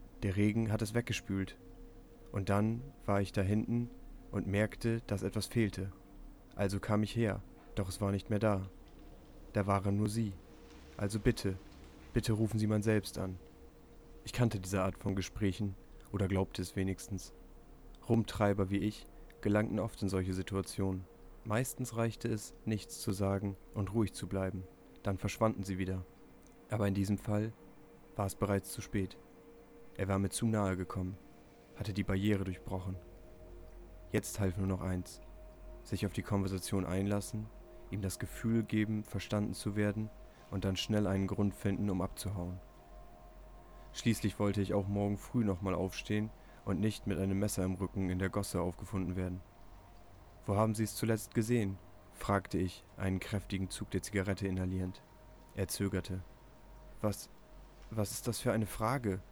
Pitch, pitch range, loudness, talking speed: 100 Hz, 95-105 Hz, -36 LUFS, 160 wpm